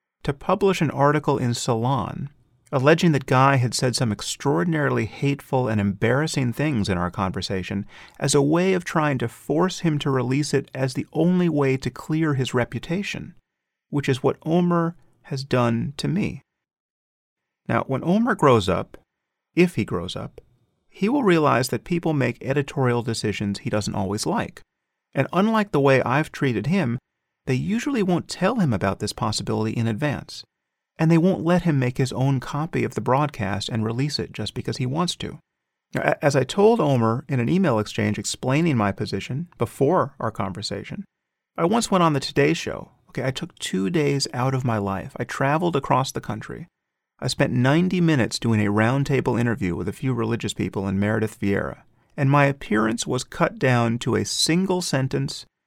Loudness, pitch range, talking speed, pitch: -23 LUFS, 115-155 Hz, 180 wpm, 135 Hz